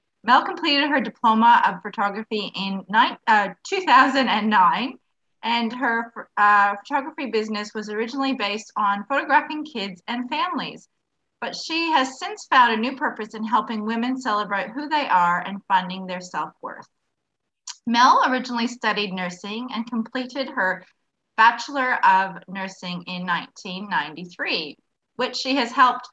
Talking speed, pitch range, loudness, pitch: 135 wpm, 200-265 Hz, -22 LUFS, 230 Hz